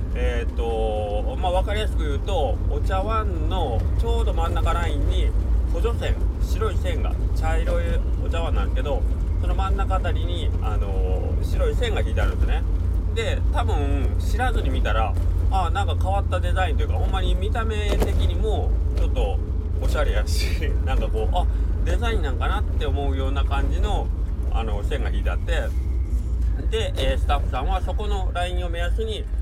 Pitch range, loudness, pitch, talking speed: 80-90 Hz, -24 LUFS, 85 Hz, 350 characters per minute